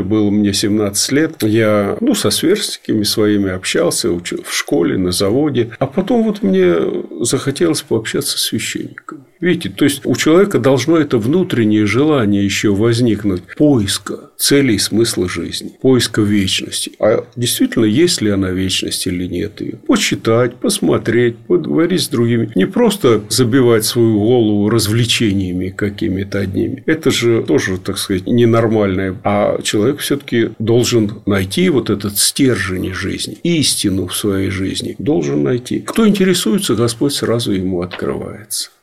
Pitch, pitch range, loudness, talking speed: 110 Hz, 100-130 Hz, -15 LUFS, 140 wpm